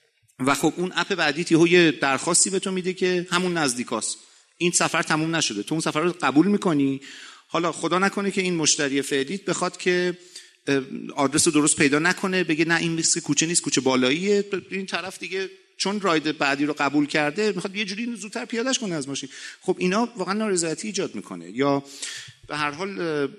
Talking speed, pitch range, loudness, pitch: 185 wpm, 145-190 Hz, -23 LUFS, 170 Hz